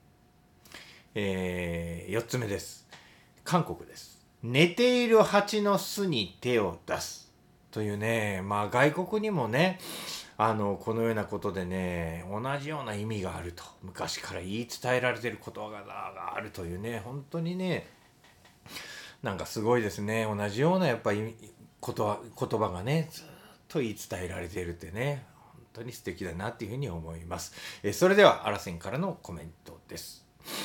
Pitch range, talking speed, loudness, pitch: 95-140 Hz, 300 characters per minute, -30 LUFS, 115 Hz